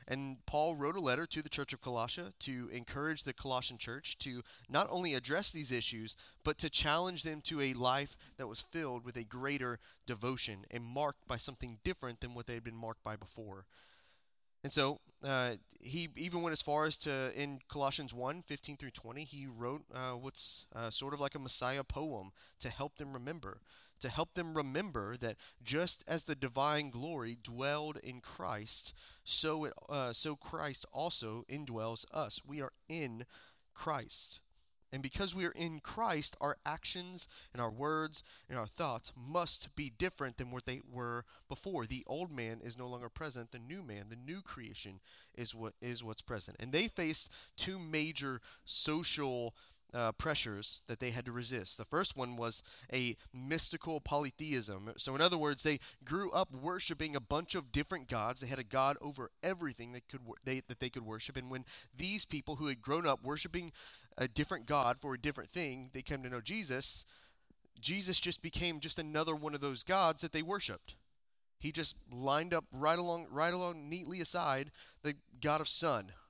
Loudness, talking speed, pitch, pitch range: -33 LUFS, 185 wpm, 135 Hz, 120-155 Hz